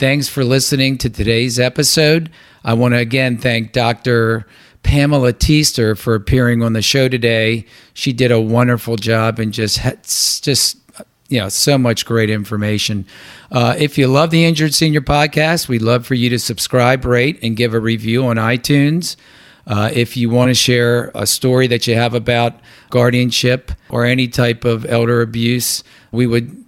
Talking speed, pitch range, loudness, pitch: 175 wpm, 115-130 Hz, -14 LUFS, 120 Hz